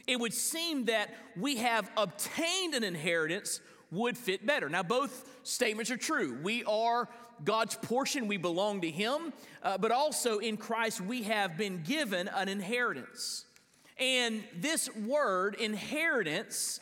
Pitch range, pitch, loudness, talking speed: 210-255 Hz, 230 Hz, -32 LUFS, 145 wpm